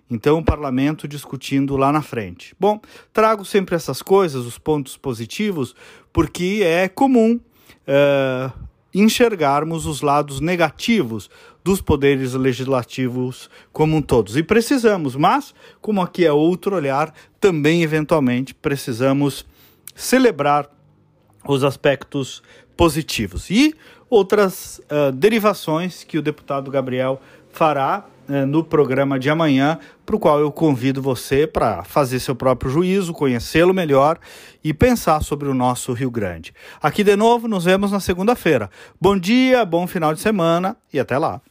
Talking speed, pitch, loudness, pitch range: 135 wpm, 150 Hz, -18 LUFS, 135-190 Hz